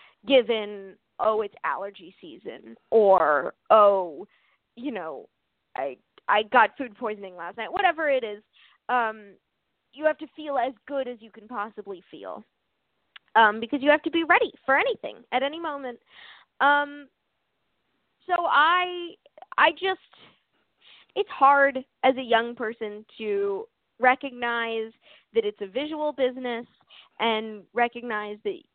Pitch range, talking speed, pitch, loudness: 220-300 Hz, 135 wpm, 250 Hz, -24 LUFS